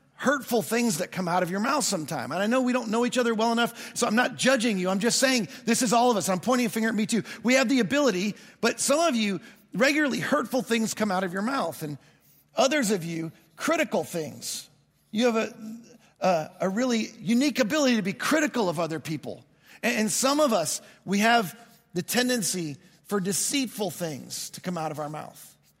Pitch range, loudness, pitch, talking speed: 190-250 Hz, -26 LUFS, 230 Hz, 215 wpm